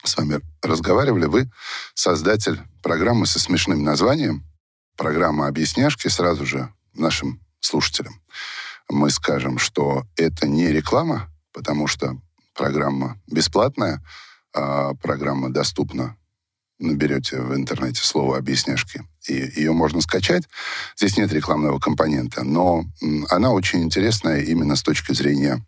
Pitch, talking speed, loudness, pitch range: 75 Hz, 115 wpm, -21 LUFS, 70-80 Hz